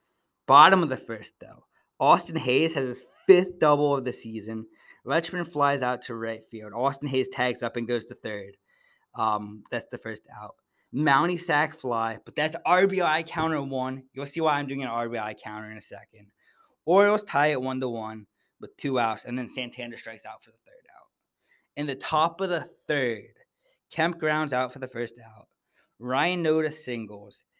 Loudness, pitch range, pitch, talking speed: -26 LUFS, 115-155 Hz, 130 Hz, 185 wpm